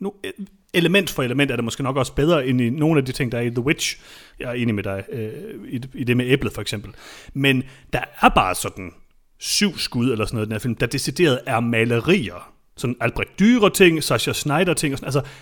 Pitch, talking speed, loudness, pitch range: 130 Hz, 220 wpm, -20 LUFS, 115-155 Hz